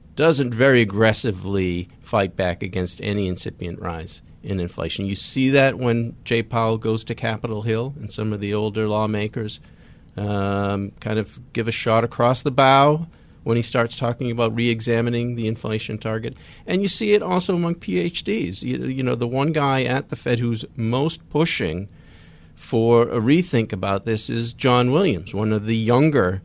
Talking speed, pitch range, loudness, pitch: 170 wpm, 100-125 Hz, -21 LUFS, 115 Hz